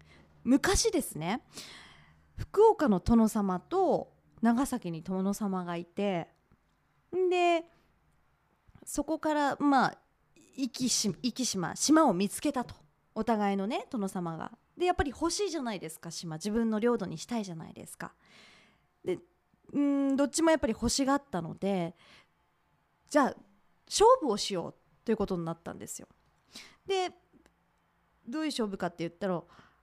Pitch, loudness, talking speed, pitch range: 230 Hz, -30 LUFS, 265 characters per minute, 185-290 Hz